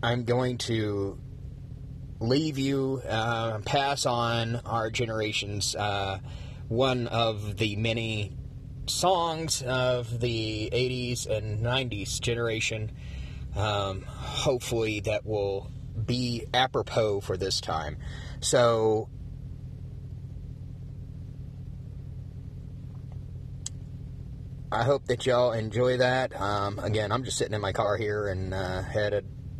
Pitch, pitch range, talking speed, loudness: 120 Hz, 110-125 Hz, 100 wpm, -28 LUFS